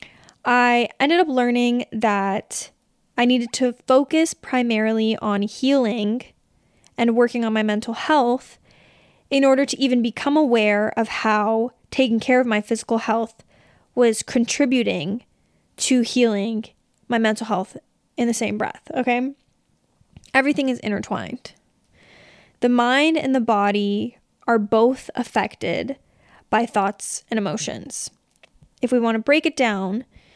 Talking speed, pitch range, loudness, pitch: 130 wpm, 220-255 Hz, -21 LUFS, 235 Hz